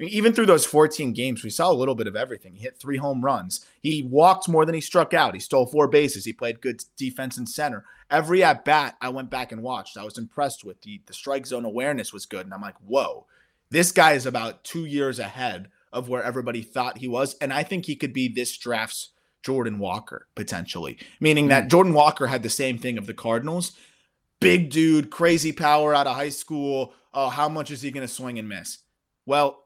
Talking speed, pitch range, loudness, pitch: 225 wpm, 125-155 Hz, -23 LUFS, 140 Hz